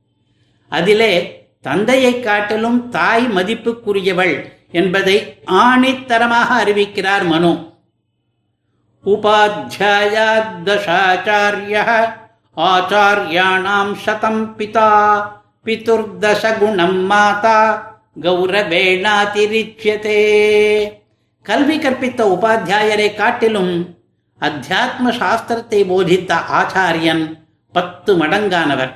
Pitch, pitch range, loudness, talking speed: 210 Hz, 190-220 Hz, -14 LUFS, 50 wpm